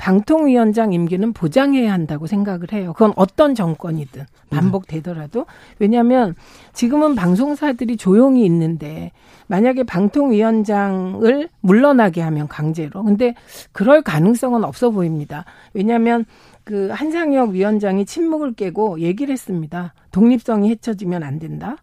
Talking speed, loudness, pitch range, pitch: 325 characters per minute, -17 LUFS, 175-245 Hz, 205 Hz